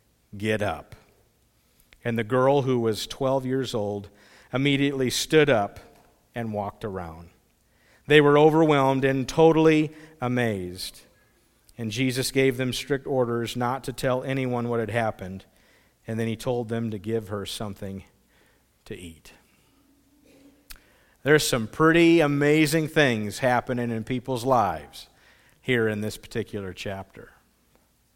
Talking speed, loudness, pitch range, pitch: 130 wpm, -24 LUFS, 110-140 Hz, 125 Hz